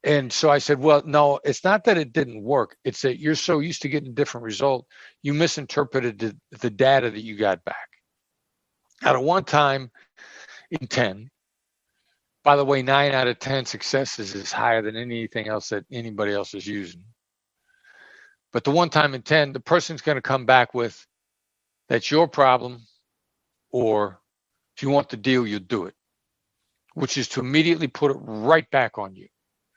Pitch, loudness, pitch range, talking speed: 135 Hz, -22 LUFS, 115-150 Hz, 180 wpm